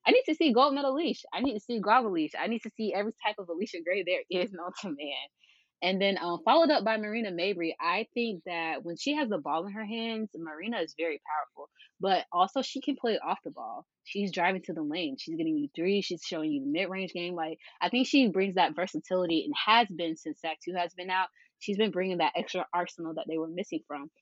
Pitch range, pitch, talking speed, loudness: 175-255 Hz, 195 Hz, 250 wpm, -30 LUFS